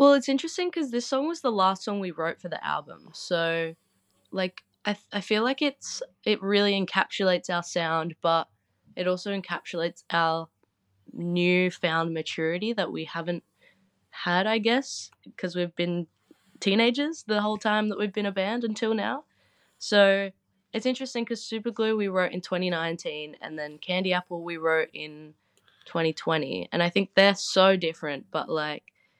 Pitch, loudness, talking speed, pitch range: 185 Hz, -27 LUFS, 165 wpm, 165-215 Hz